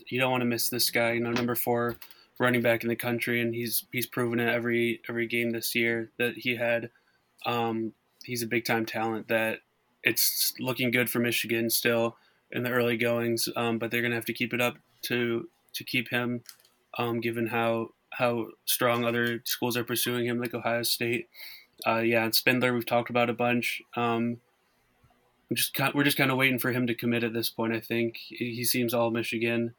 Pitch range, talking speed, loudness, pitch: 115-120 Hz, 205 wpm, -28 LUFS, 120 Hz